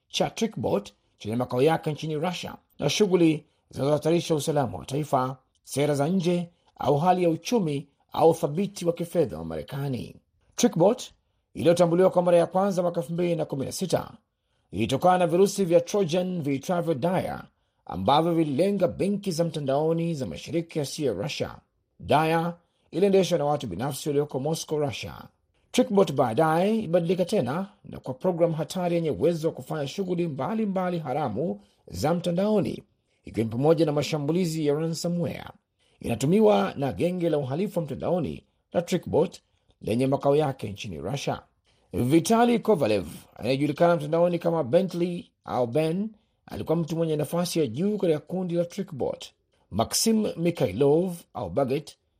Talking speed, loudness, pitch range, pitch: 135 wpm, -26 LUFS, 145-180 Hz, 165 Hz